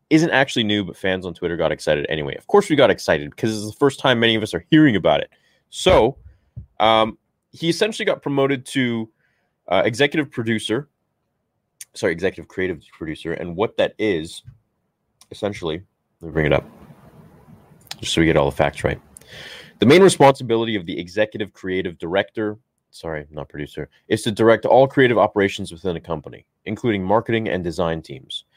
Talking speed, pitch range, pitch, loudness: 180 wpm, 95-130 Hz, 110 Hz, -19 LUFS